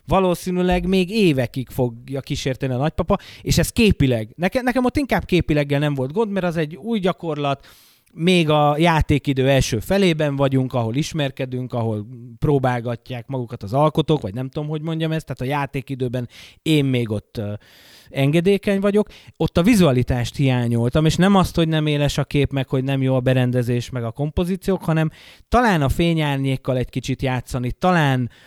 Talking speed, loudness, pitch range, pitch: 165 wpm, -20 LUFS, 125-170 Hz, 140 Hz